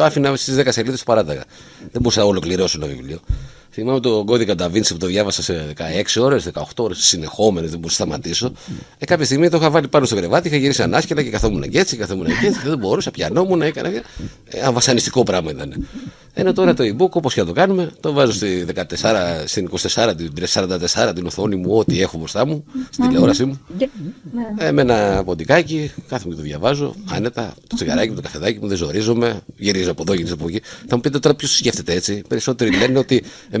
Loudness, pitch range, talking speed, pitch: -18 LUFS, 90-145 Hz, 215 wpm, 115 Hz